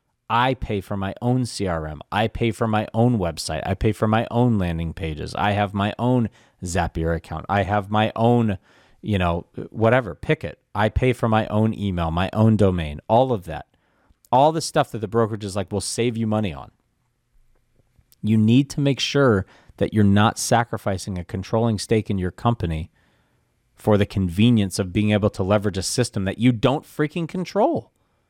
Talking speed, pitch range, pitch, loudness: 190 wpm, 95-120 Hz, 110 Hz, -22 LUFS